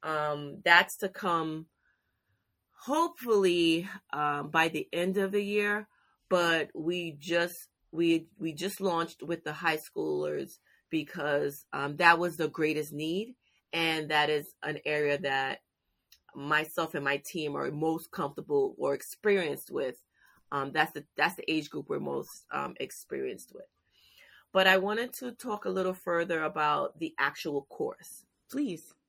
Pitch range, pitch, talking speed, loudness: 155-200 Hz, 170 Hz, 145 wpm, -30 LUFS